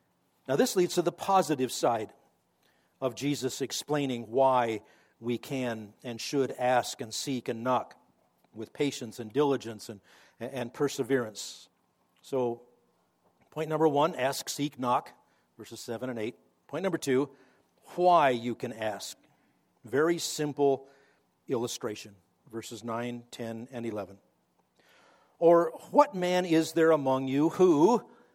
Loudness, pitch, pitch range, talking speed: -29 LUFS, 130 Hz, 115-145 Hz, 130 wpm